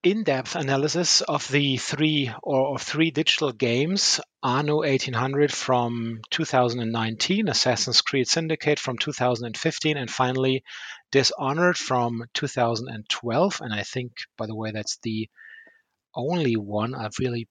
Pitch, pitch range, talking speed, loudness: 130 Hz, 120-150 Hz, 125 wpm, -24 LUFS